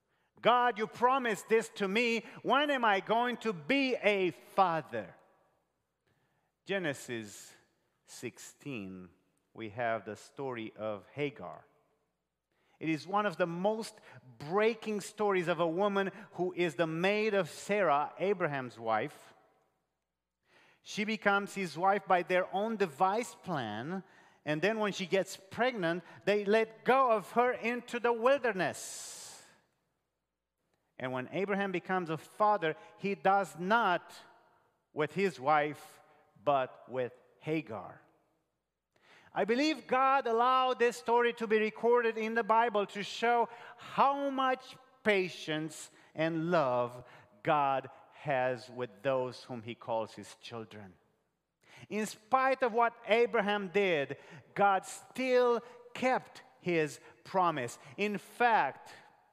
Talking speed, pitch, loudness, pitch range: 120 wpm, 190 Hz, -32 LUFS, 145-225 Hz